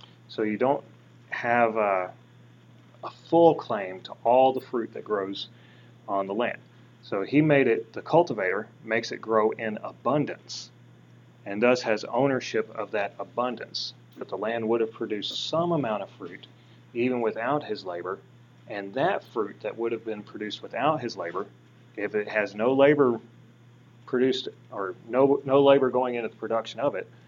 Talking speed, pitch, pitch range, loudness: 165 wpm, 110 Hz, 95-125 Hz, -26 LUFS